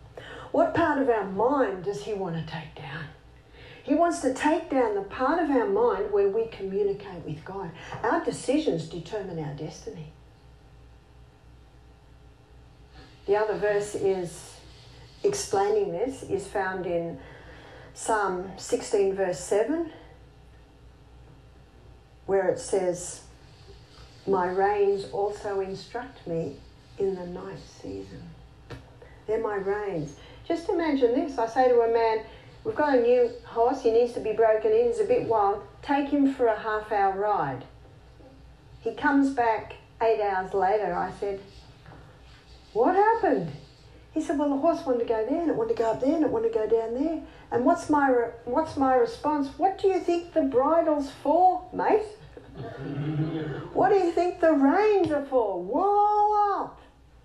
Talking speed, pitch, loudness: 155 wpm, 230 Hz, -26 LUFS